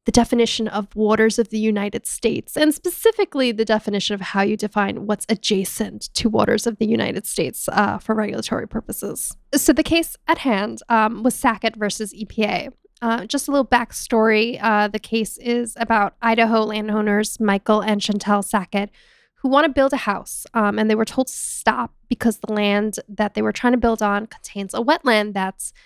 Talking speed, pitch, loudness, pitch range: 190 wpm, 220 Hz, -20 LUFS, 210-240 Hz